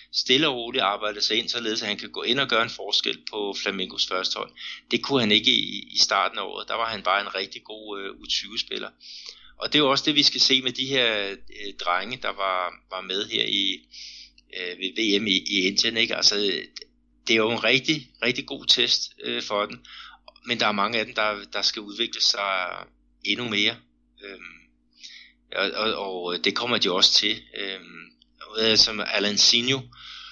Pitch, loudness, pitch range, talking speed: 100 Hz, -23 LUFS, 90-110 Hz, 200 wpm